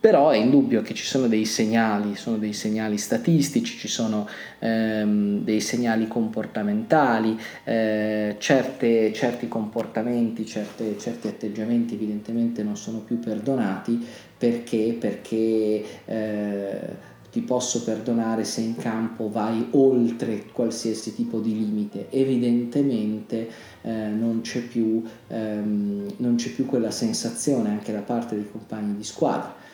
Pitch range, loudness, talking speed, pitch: 110-120 Hz, -24 LUFS, 125 wpm, 110 Hz